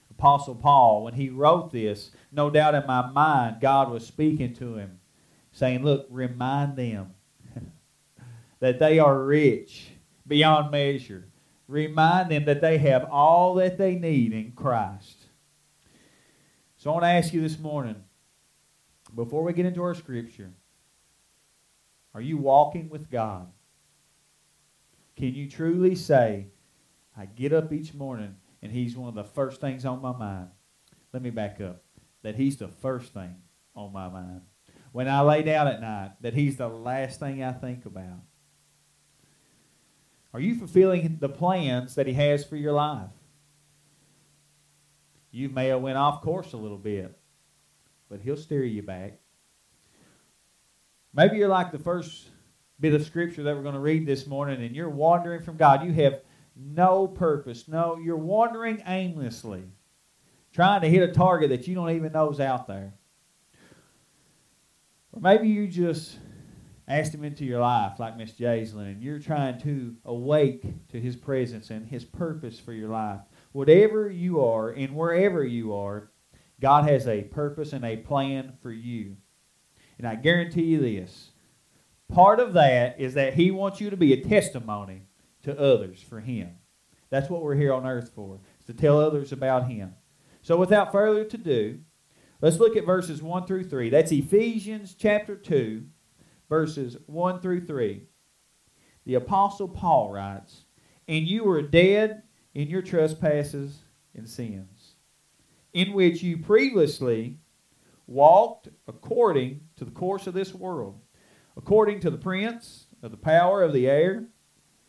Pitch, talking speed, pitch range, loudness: 140 Hz, 155 wpm, 120-165 Hz, -24 LUFS